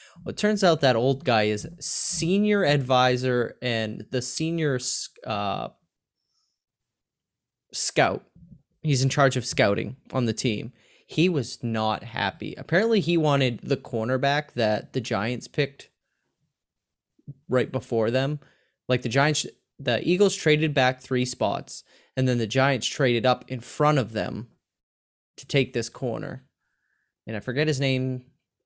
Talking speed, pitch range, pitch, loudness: 140 wpm, 120-145 Hz, 130 Hz, -24 LUFS